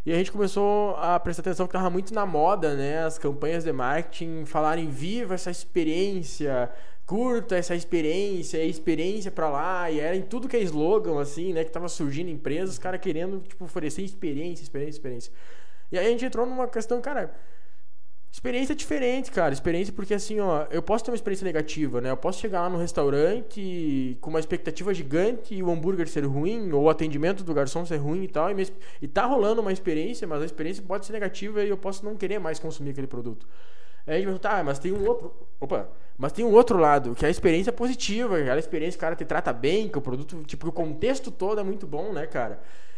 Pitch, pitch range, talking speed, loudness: 175 Hz, 155-200 Hz, 215 wpm, -27 LUFS